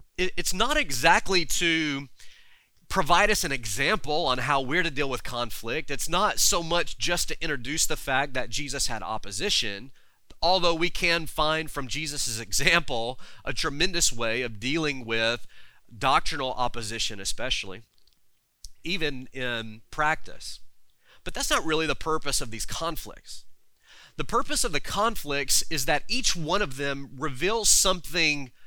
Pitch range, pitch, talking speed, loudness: 125-170 Hz, 150 Hz, 145 wpm, -26 LUFS